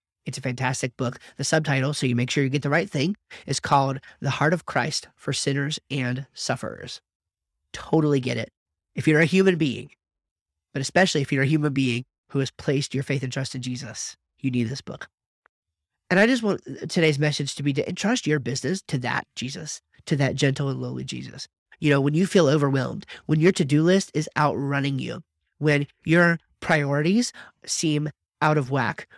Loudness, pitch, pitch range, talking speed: -24 LUFS, 140 Hz, 130-155 Hz, 195 wpm